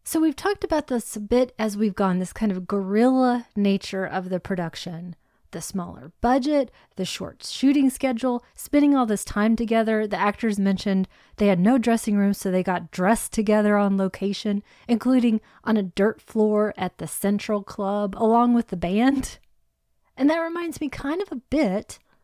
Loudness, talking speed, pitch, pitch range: -23 LUFS, 180 wpm, 215 Hz, 195-250 Hz